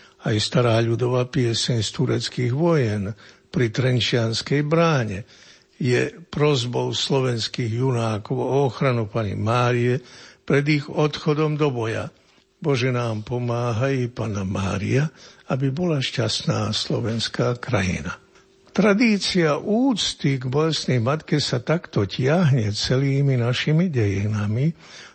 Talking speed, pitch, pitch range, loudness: 105 wpm, 125 Hz, 115-150 Hz, -22 LUFS